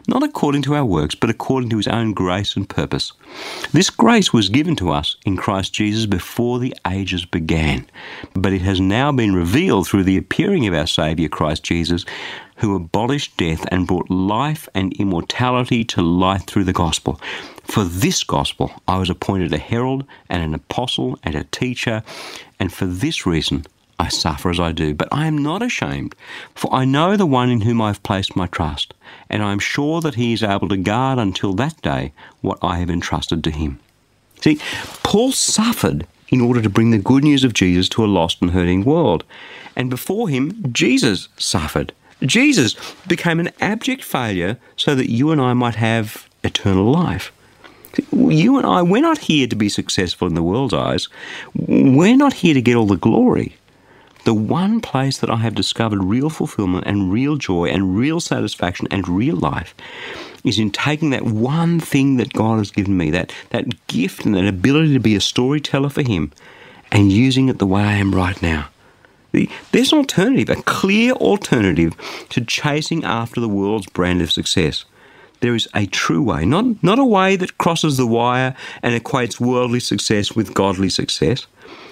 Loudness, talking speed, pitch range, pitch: -18 LUFS, 190 wpm, 95-135 Hz, 110 Hz